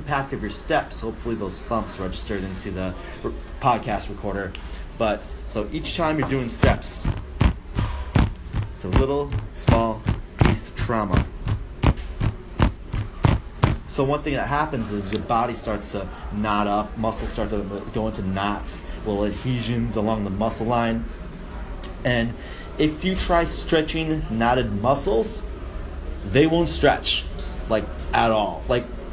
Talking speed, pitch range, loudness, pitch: 130 wpm, 100-120 Hz, -24 LUFS, 110 Hz